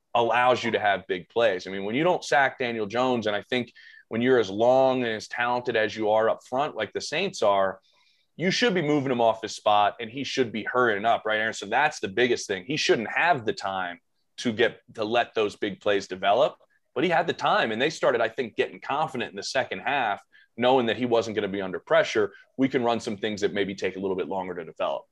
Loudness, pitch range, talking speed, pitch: -25 LUFS, 110-130 Hz, 255 wpm, 115 Hz